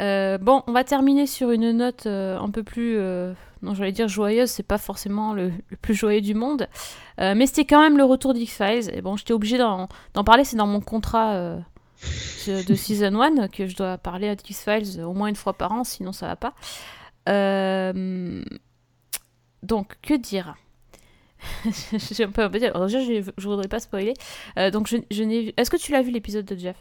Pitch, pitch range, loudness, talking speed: 210 Hz, 195-235 Hz, -23 LUFS, 205 wpm